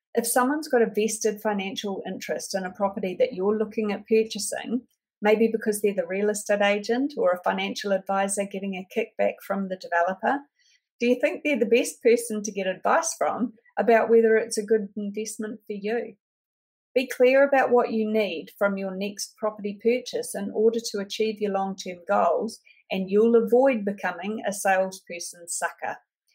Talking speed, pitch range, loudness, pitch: 175 wpm, 200-235 Hz, -25 LUFS, 215 Hz